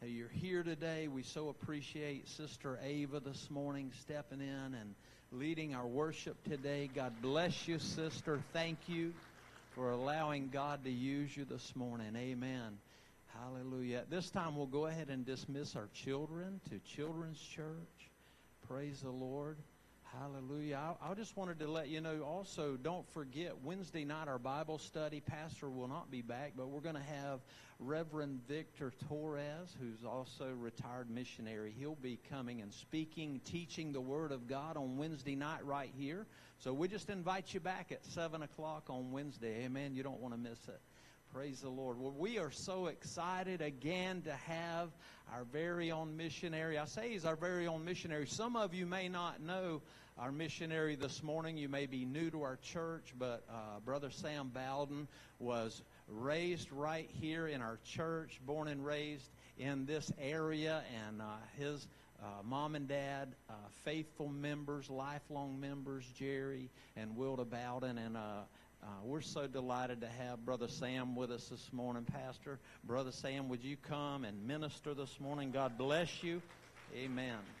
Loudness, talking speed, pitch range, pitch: -44 LUFS, 170 wpm, 130-155 Hz, 145 Hz